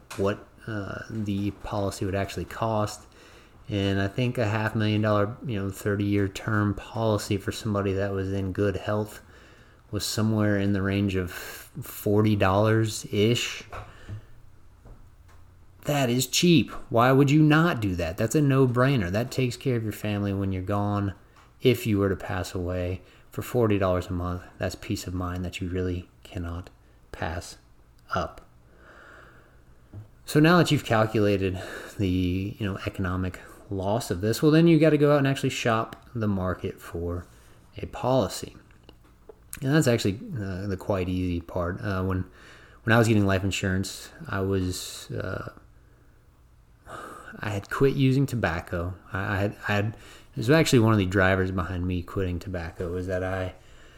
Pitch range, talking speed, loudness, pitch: 95-110 Hz, 165 wpm, -26 LUFS, 100 Hz